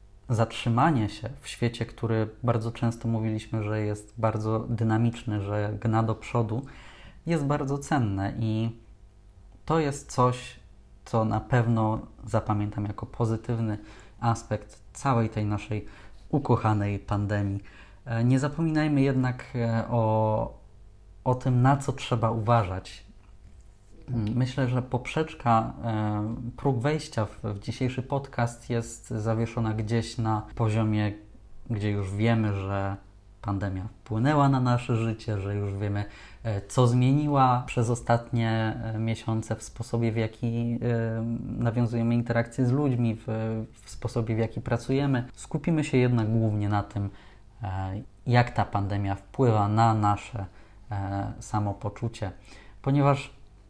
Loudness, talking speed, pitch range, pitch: -28 LUFS, 115 wpm, 105-120 Hz, 115 Hz